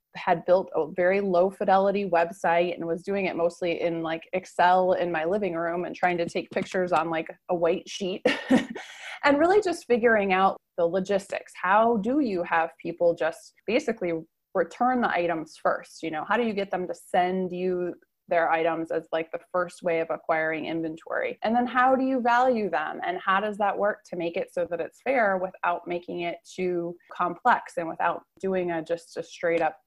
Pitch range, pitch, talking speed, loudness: 170-205 Hz, 180 Hz, 200 wpm, -26 LUFS